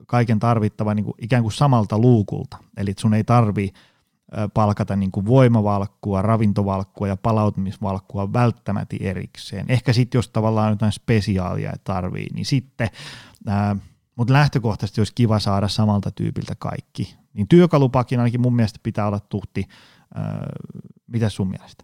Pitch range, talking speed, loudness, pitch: 100-125 Hz, 135 wpm, -21 LUFS, 110 Hz